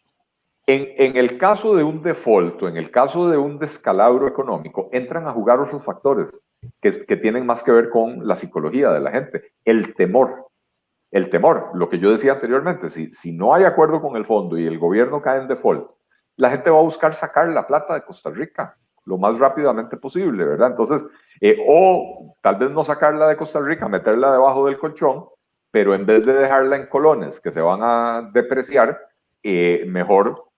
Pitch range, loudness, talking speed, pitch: 115-155 Hz, -18 LUFS, 195 wpm, 135 Hz